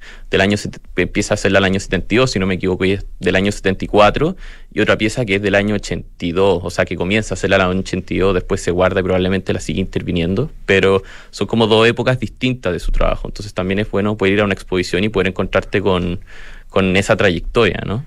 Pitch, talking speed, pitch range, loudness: 95 Hz, 235 wpm, 95-105 Hz, -17 LUFS